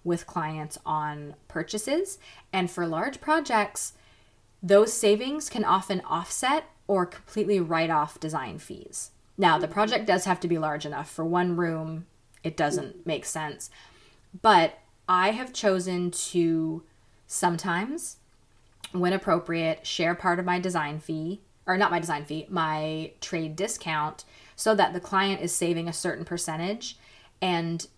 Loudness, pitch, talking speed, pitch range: -27 LUFS, 175 Hz, 145 wpm, 160-195 Hz